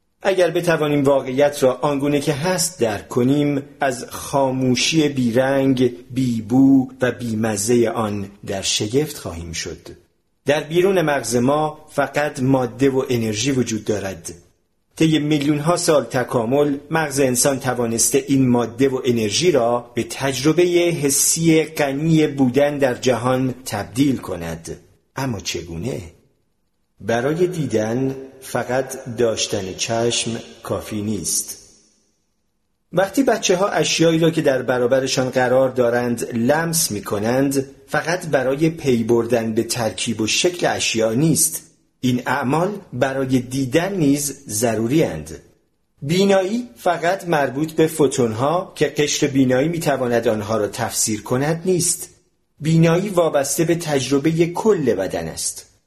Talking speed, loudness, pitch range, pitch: 120 wpm, -19 LUFS, 120-155 Hz, 135 Hz